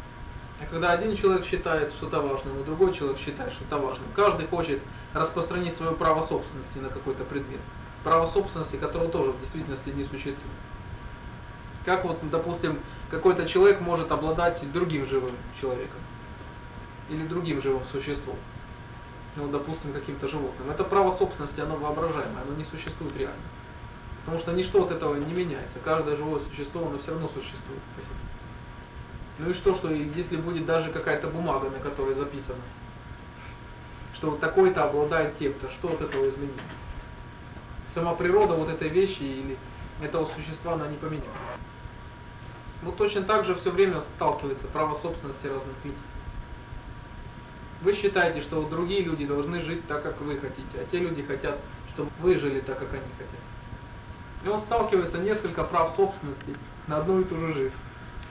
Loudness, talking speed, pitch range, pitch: -28 LUFS, 155 wpm, 135-170 Hz, 150 Hz